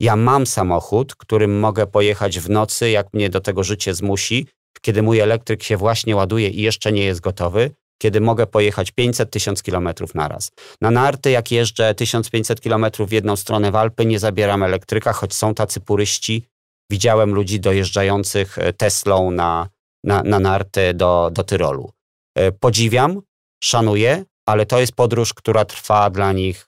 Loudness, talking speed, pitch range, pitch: -18 LUFS, 160 wpm, 100-115 Hz, 105 Hz